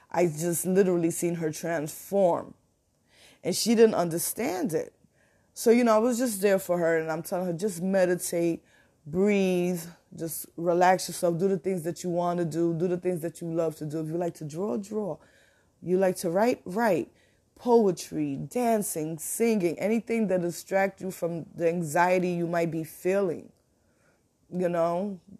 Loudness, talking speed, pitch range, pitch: -27 LUFS, 175 wpm, 170-195 Hz, 175 Hz